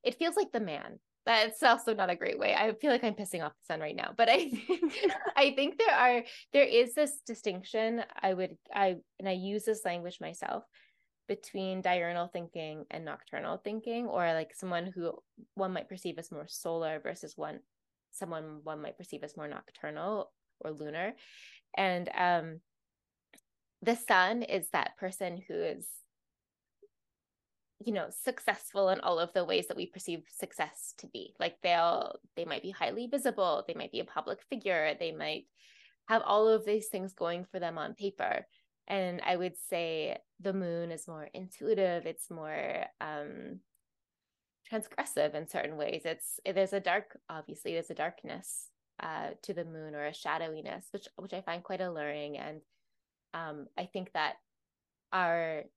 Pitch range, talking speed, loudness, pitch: 170-225 Hz, 170 wpm, -33 LUFS, 185 Hz